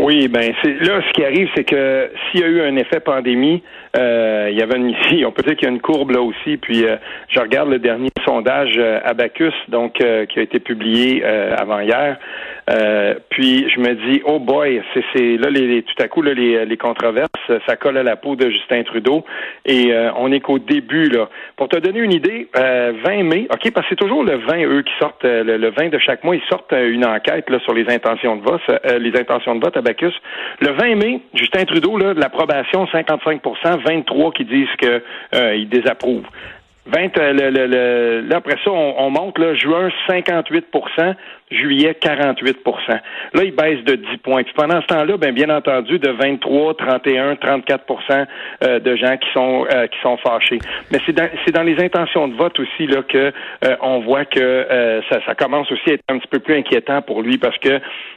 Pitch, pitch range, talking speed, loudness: 135 Hz, 120-160 Hz, 220 wpm, -16 LUFS